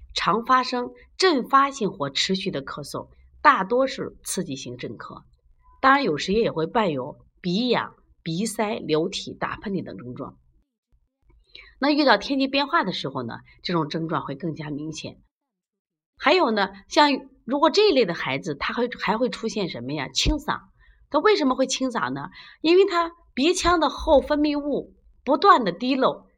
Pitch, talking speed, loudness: 230 Hz, 245 characters per minute, -23 LUFS